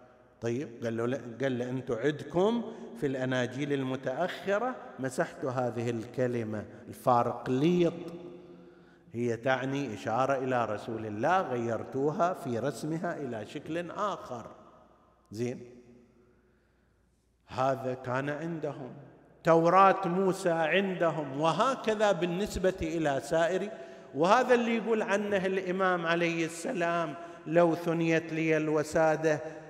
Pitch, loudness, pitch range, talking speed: 155 Hz, -30 LUFS, 125-170 Hz, 90 wpm